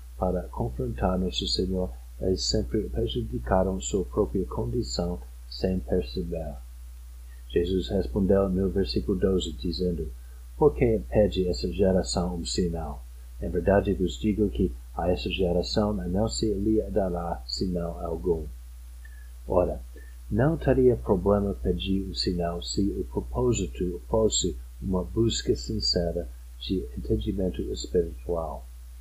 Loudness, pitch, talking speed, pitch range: -27 LUFS, 90 Hz, 120 wpm, 65-95 Hz